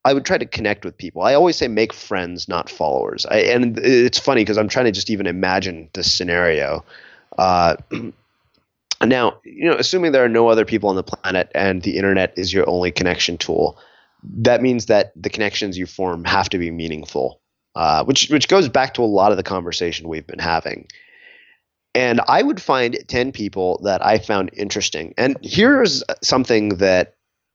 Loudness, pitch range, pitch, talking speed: -18 LUFS, 90-115 Hz, 100 Hz, 190 wpm